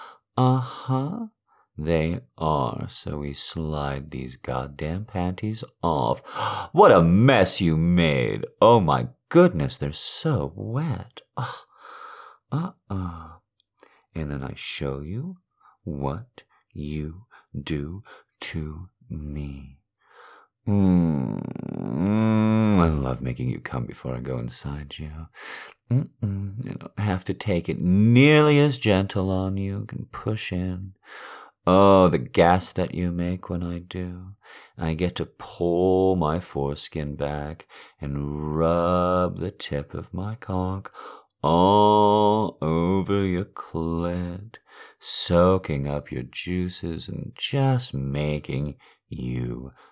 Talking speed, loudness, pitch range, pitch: 115 wpm, -23 LUFS, 75-105 Hz, 90 Hz